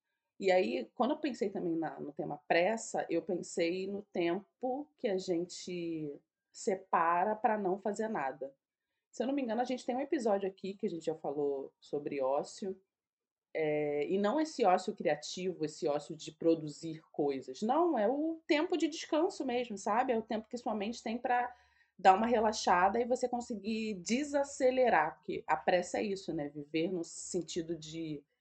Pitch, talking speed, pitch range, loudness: 190 Hz, 175 wpm, 165-245 Hz, -34 LUFS